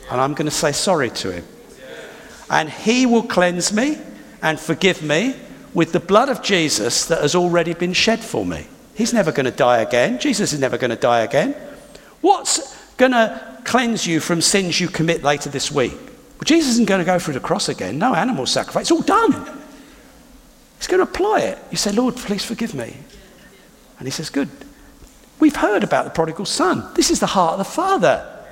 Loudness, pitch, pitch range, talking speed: -18 LUFS, 220 Hz, 165-265 Hz, 205 wpm